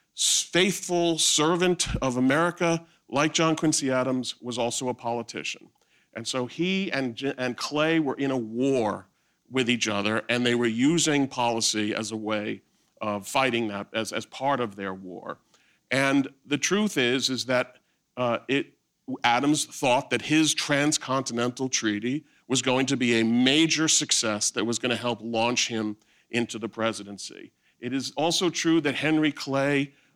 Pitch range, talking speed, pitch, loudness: 115-150 Hz, 160 wpm, 130 Hz, -25 LUFS